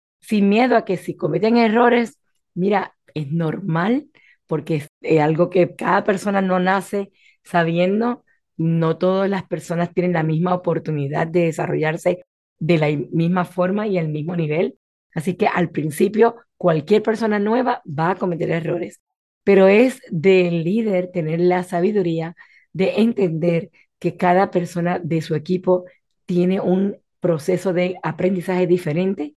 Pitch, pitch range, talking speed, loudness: 180 Hz, 170-195 Hz, 140 wpm, -19 LUFS